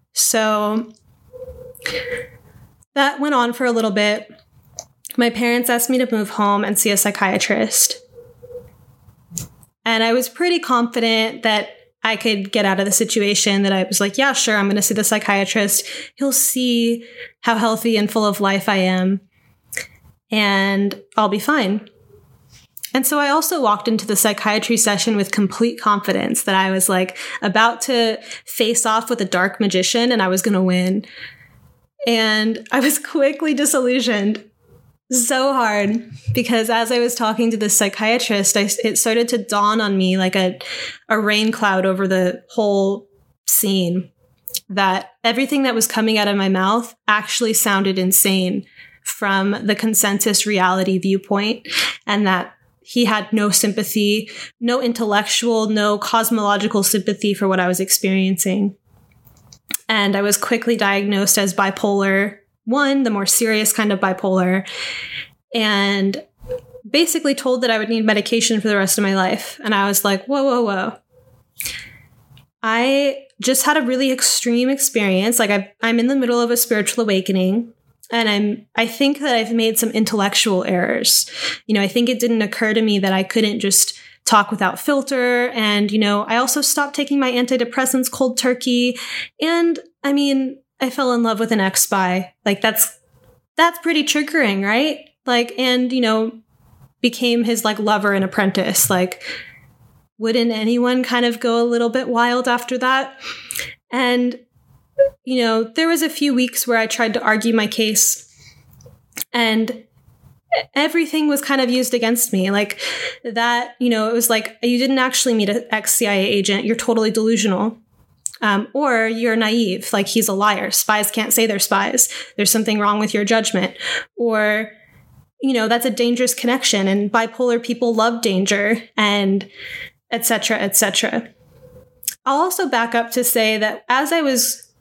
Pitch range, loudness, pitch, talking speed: 200-245 Hz, -17 LUFS, 220 Hz, 160 wpm